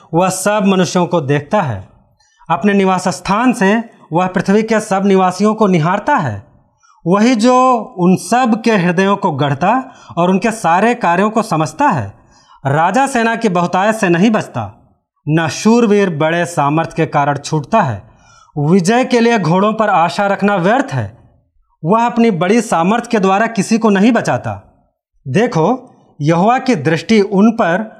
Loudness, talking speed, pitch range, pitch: -13 LUFS, 155 wpm, 160-220 Hz, 190 Hz